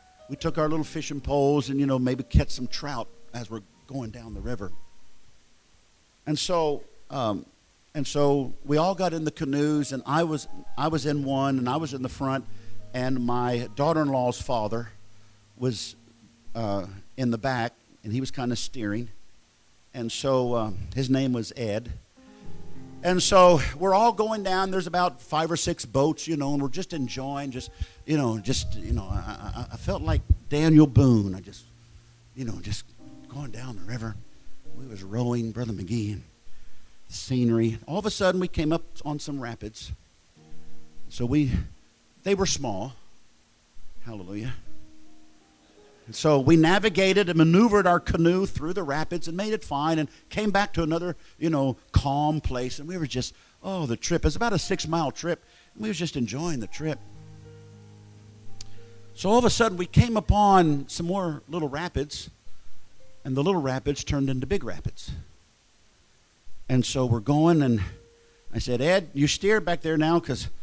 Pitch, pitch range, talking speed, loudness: 130 Hz, 110-155 Hz, 175 wpm, -26 LUFS